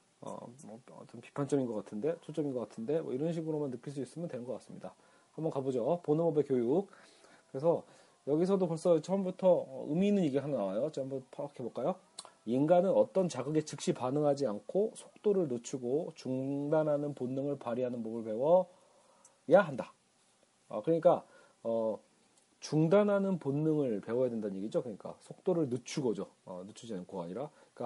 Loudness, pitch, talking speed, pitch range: -33 LUFS, 150 Hz, 350 characters per minute, 130-175 Hz